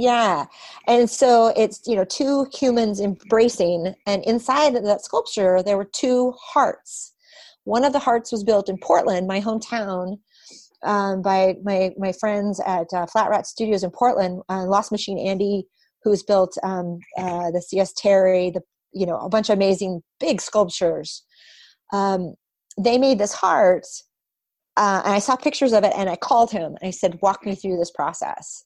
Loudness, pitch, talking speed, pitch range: -21 LUFS, 200 Hz, 175 wpm, 185-230 Hz